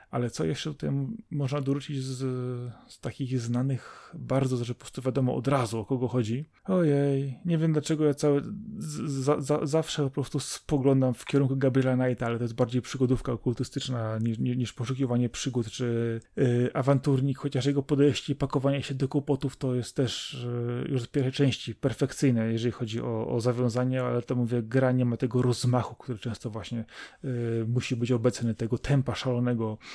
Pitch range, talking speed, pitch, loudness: 120-140 Hz, 180 wpm, 130 Hz, -28 LUFS